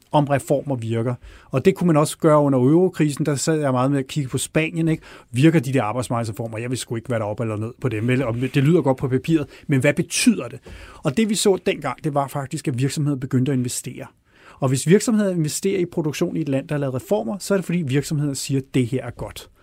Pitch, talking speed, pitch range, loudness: 145 Hz, 250 wpm, 130-160 Hz, -21 LUFS